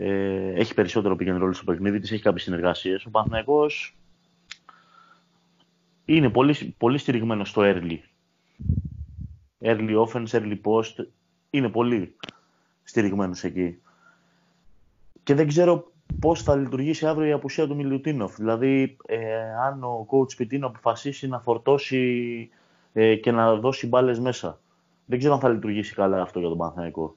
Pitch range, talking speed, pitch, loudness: 100-135 Hz, 135 wpm, 115 Hz, -24 LUFS